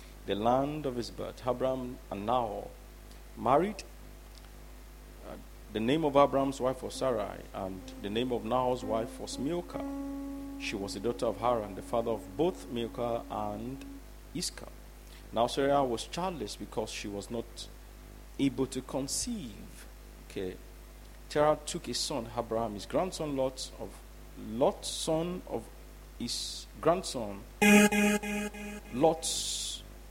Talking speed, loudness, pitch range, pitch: 130 wpm, -32 LUFS, 115-160 Hz, 130 Hz